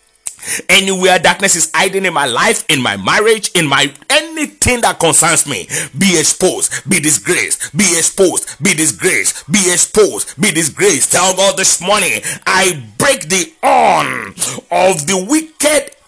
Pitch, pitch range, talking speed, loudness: 185 Hz, 160-210 Hz, 145 wpm, -11 LUFS